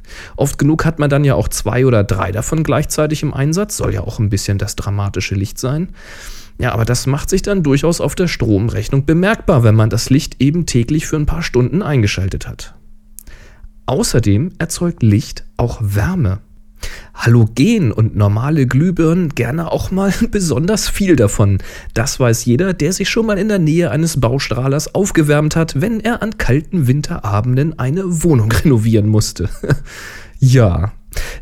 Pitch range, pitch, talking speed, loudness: 110-165 Hz, 130 Hz, 160 wpm, -15 LUFS